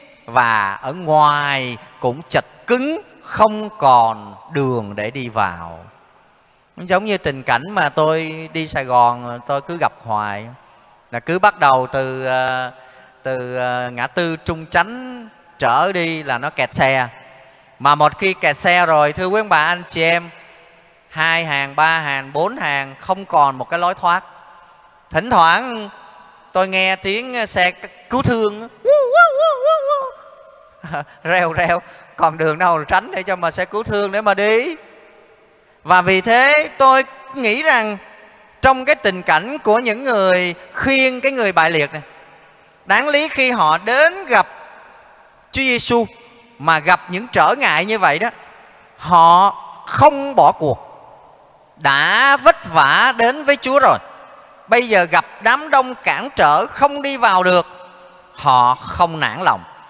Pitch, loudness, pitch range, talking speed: 175 Hz, -15 LUFS, 150-215 Hz, 150 wpm